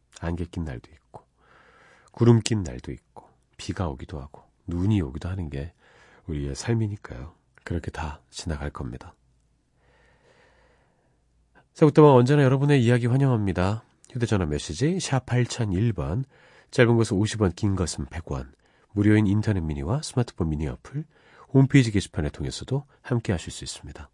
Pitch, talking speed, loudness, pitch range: 100 Hz, 300 characters per minute, -24 LUFS, 75-120 Hz